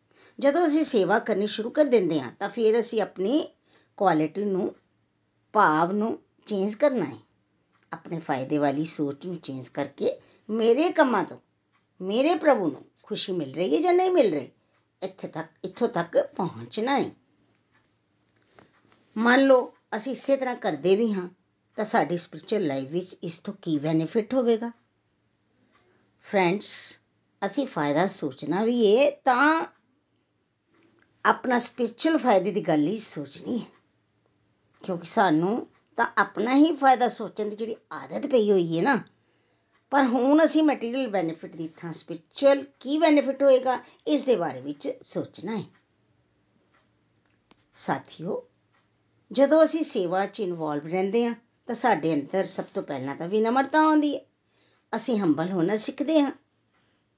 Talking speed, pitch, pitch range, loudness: 140 wpm, 215 Hz, 170-265 Hz, -25 LUFS